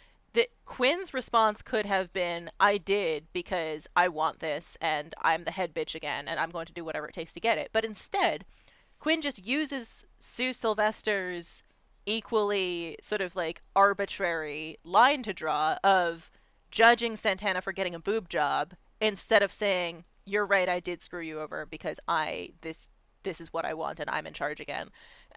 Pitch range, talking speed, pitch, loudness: 170-220 Hz, 175 wpm, 195 Hz, -29 LUFS